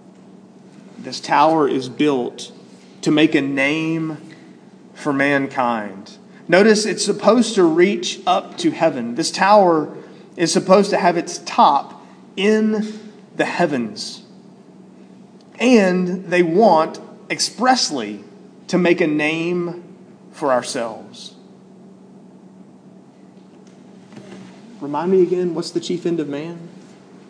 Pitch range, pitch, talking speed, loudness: 165-205 Hz, 185 Hz, 105 wpm, -18 LUFS